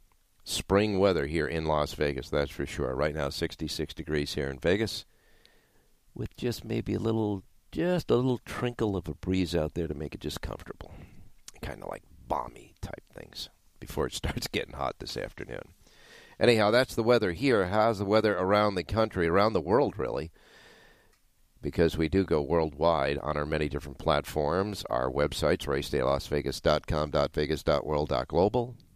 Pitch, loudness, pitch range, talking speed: 85 Hz, -29 LUFS, 75-105 Hz, 155 wpm